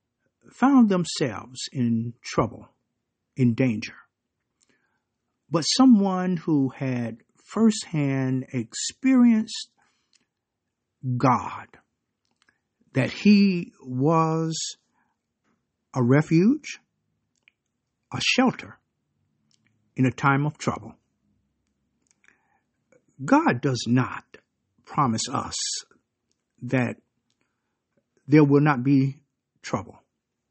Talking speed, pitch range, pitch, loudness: 70 wpm, 120-175 Hz, 135 Hz, -23 LUFS